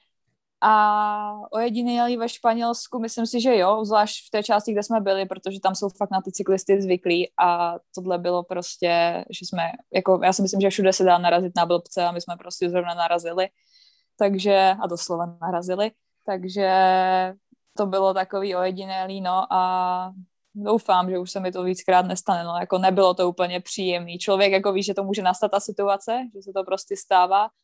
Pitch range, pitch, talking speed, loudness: 180-205 Hz, 190 Hz, 185 wpm, -22 LUFS